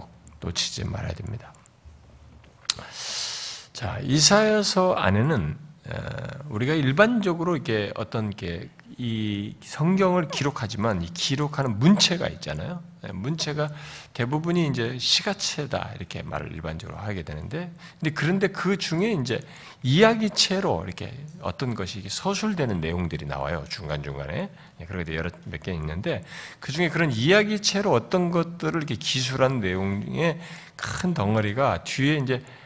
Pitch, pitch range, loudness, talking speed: 140 Hz, 105-170 Hz, -25 LUFS, 295 characters per minute